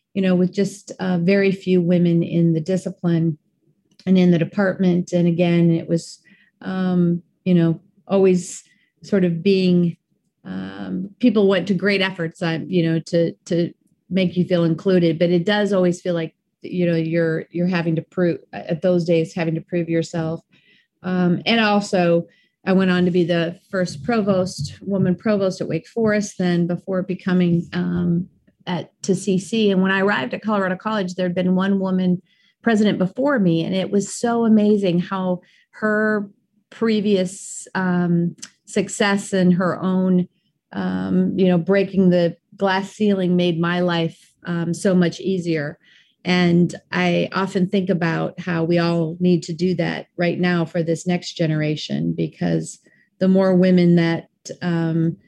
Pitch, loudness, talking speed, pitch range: 180 Hz, -20 LUFS, 160 wpm, 170-195 Hz